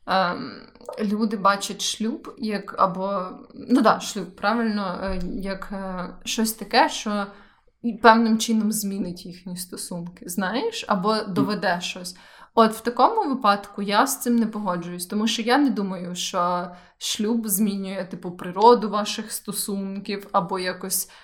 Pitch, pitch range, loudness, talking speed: 205 Hz, 190-225 Hz, -23 LUFS, 125 wpm